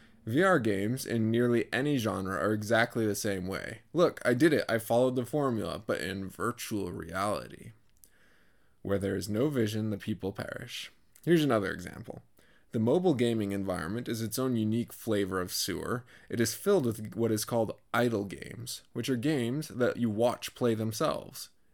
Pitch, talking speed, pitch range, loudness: 115 Hz, 170 wpm, 105-120 Hz, -31 LUFS